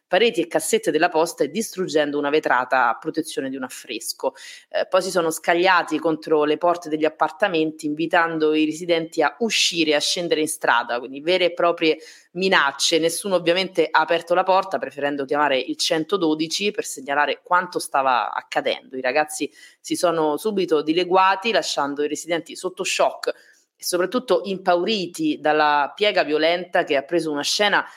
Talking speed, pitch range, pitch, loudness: 165 wpm, 155-185 Hz, 165 Hz, -21 LUFS